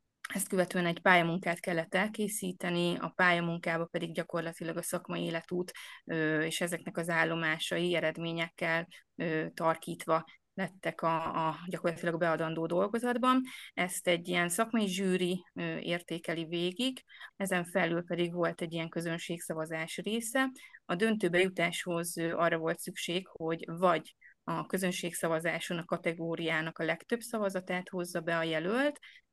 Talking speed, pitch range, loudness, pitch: 120 wpm, 165-185 Hz, -33 LUFS, 175 Hz